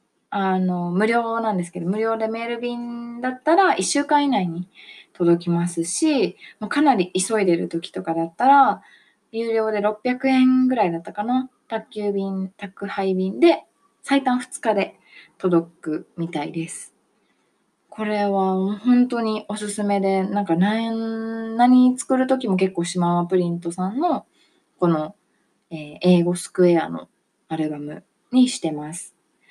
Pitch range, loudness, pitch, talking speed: 175-240 Hz, -21 LUFS, 205 Hz, 255 characters per minute